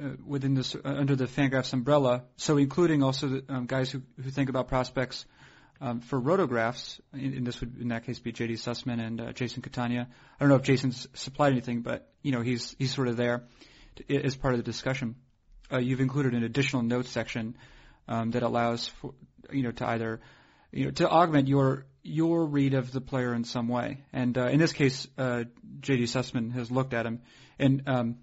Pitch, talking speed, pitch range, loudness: 130 Hz, 210 wpm, 120-135 Hz, -29 LUFS